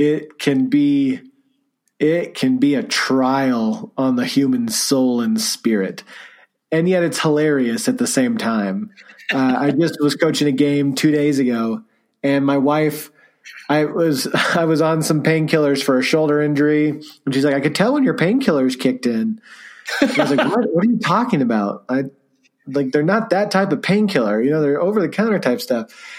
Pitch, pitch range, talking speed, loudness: 155 Hz, 140-215 Hz, 190 wpm, -18 LUFS